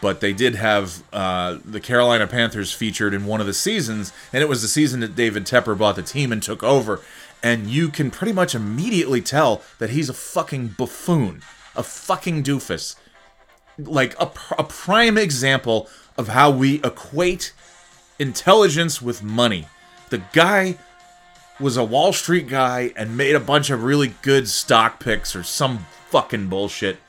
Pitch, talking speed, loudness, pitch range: 130 Hz, 170 wpm, -20 LUFS, 110-150 Hz